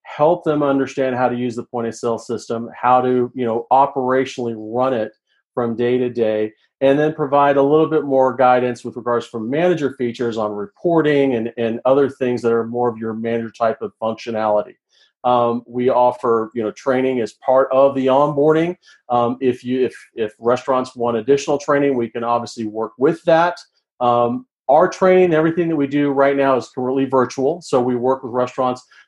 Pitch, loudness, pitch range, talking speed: 125 Hz, -18 LUFS, 120-140 Hz, 190 wpm